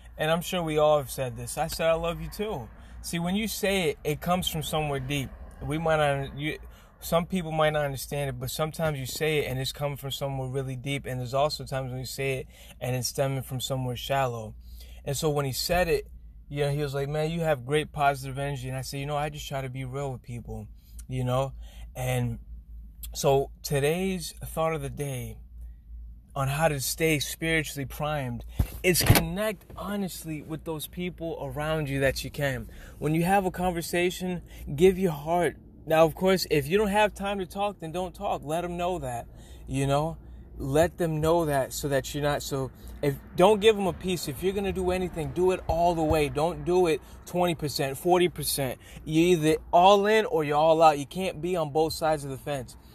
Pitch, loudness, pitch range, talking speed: 150 Hz, -27 LUFS, 135-170 Hz, 215 wpm